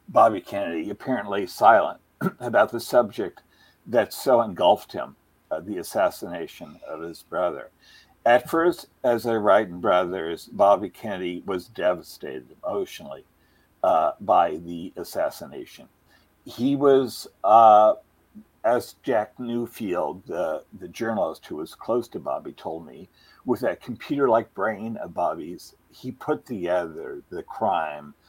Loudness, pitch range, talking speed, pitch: -24 LUFS, 90-125 Hz, 130 wpm, 105 Hz